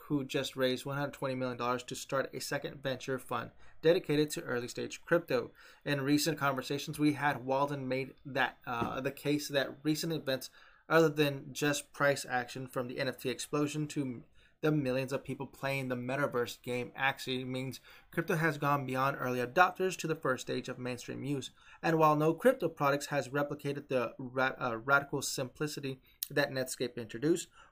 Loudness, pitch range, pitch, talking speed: -34 LUFS, 130-150 Hz, 140 Hz, 170 wpm